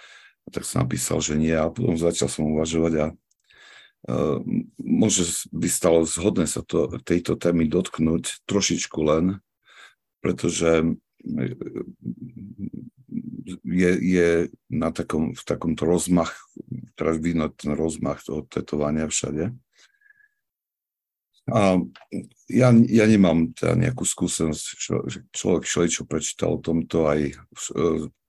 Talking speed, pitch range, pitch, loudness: 120 wpm, 80-100 Hz, 85 Hz, -23 LUFS